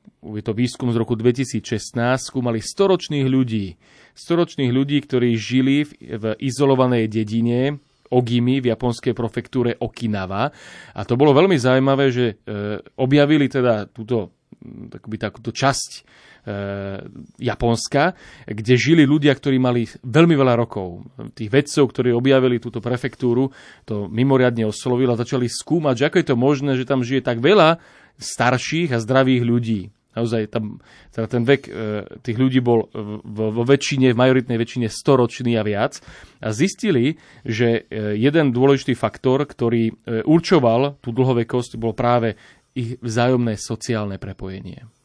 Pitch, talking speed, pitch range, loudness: 125 Hz, 140 wpm, 115-135 Hz, -19 LUFS